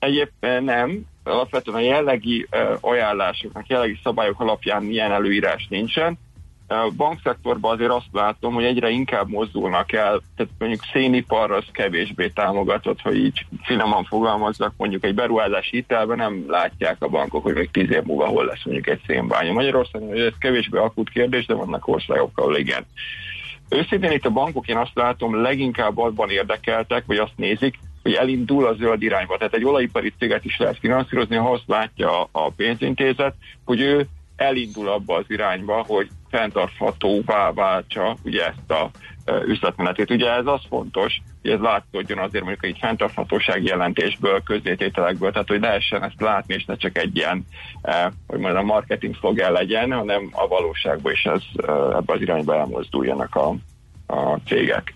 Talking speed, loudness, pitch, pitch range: 160 wpm, -21 LUFS, 120 Hz, 105-130 Hz